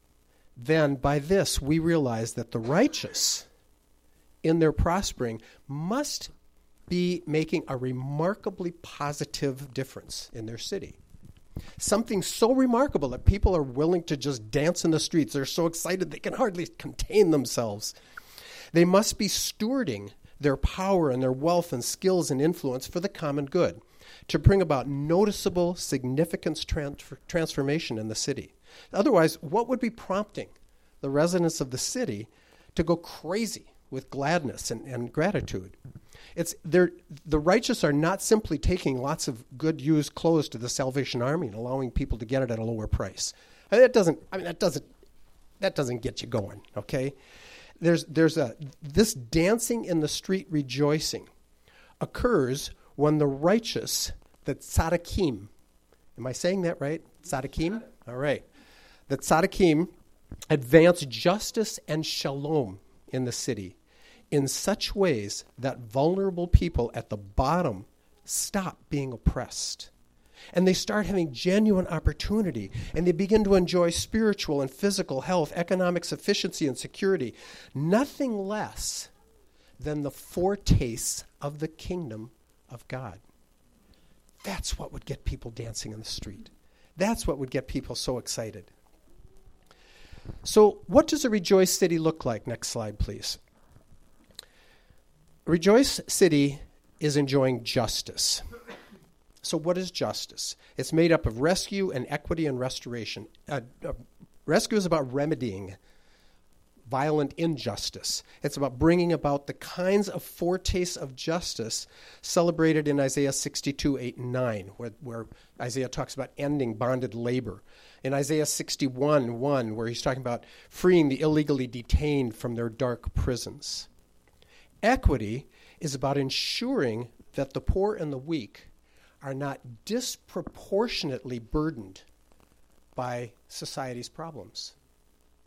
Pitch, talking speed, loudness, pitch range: 145 Hz, 135 wpm, -27 LUFS, 120-175 Hz